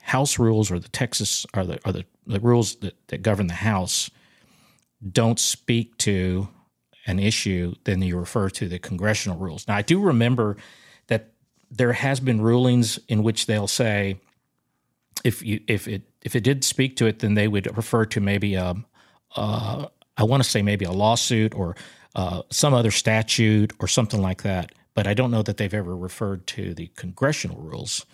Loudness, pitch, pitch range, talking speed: -23 LUFS, 110 Hz, 100-120 Hz, 185 wpm